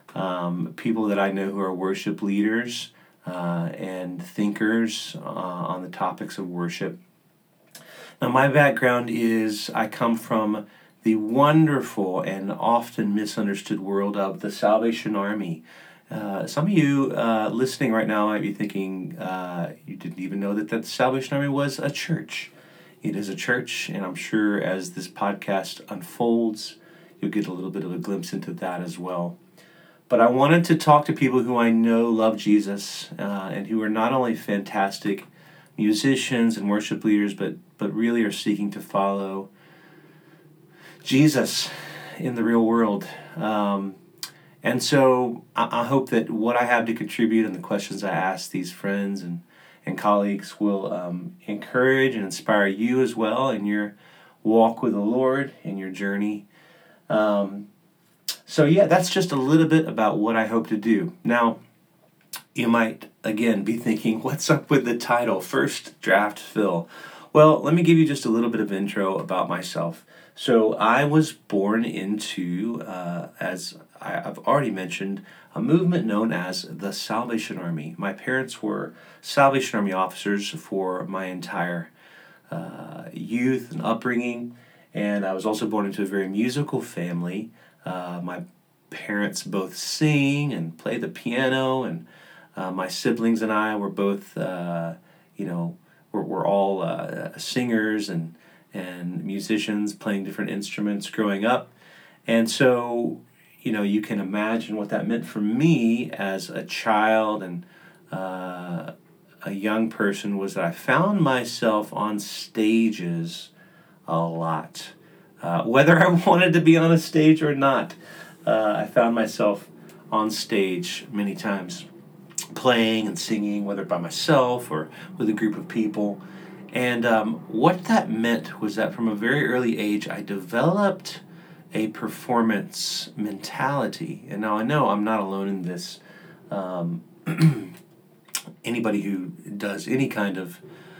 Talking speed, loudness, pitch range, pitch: 155 wpm, -24 LUFS, 100-130 Hz, 110 Hz